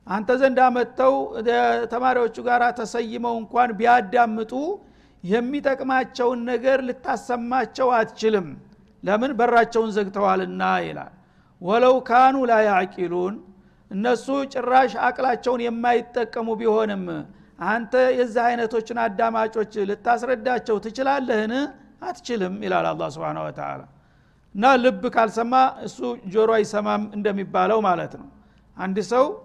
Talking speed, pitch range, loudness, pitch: 95 wpm, 215-250 Hz, -22 LUFS, 235 Hz